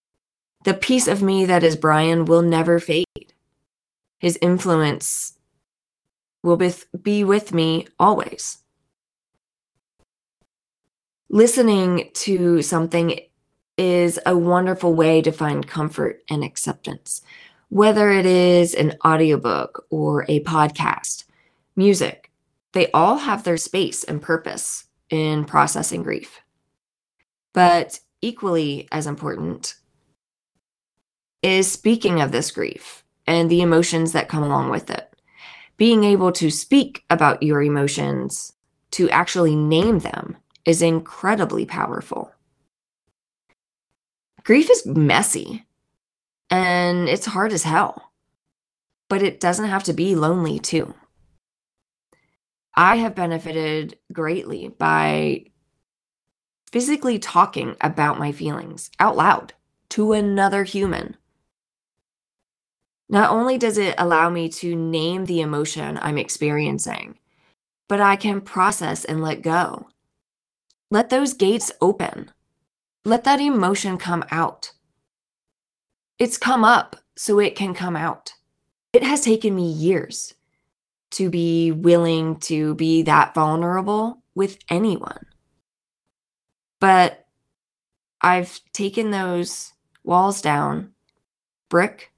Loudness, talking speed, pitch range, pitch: -19 LUFS, 110 wpm, 160-195 Hz, 175 Hz